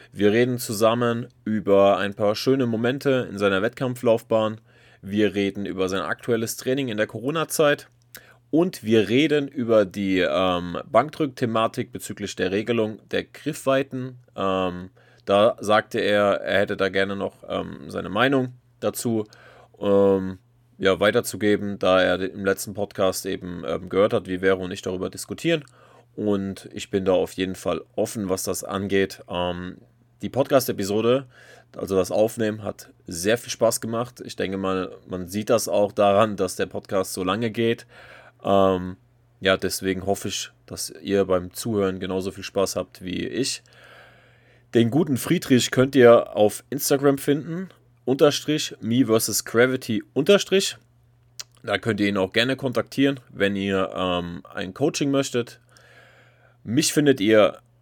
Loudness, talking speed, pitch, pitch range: -23 LUFS, 150 wpm, 110 Hz, 95-125 Hz